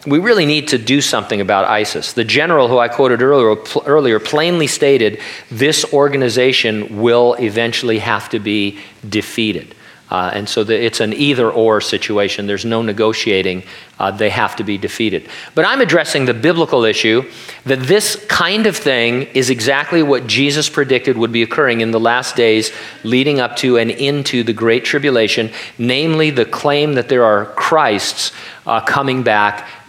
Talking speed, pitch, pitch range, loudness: 170 wpm, 120 Hz, 110-140 Hz, -14 LUFS